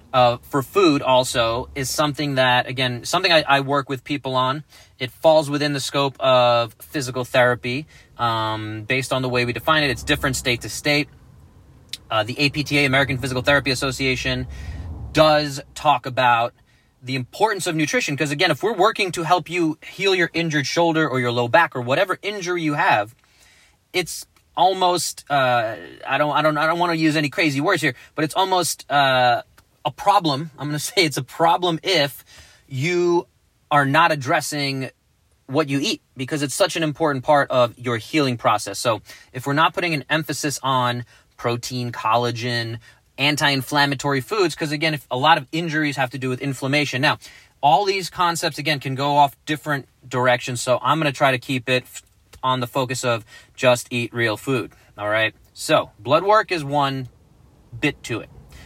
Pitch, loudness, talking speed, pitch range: 140 Hz, -20 LUFS, 180 wpm, 125-155 Hz